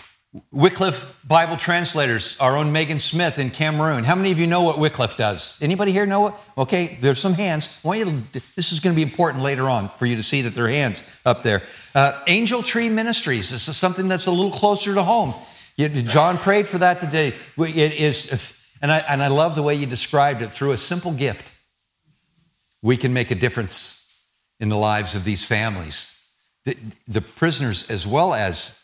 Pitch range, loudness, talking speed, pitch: 125-175 Hz, -20 LUFS, 205 wpm, 150 Hz